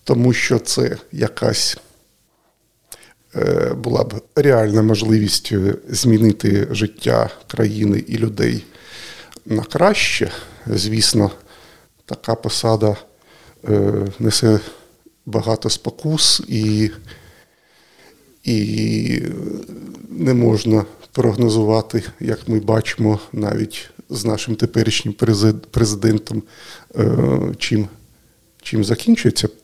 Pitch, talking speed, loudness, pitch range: 110 Hz, 75 wpm, -18 LUFS, 105-115 Hz